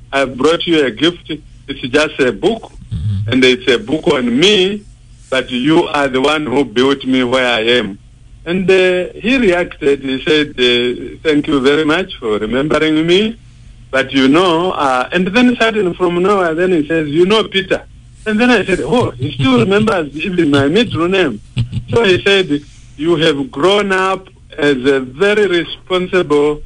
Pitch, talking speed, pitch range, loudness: 150 Hz, 180 wpm, 130-185 Hz, -13 LUFS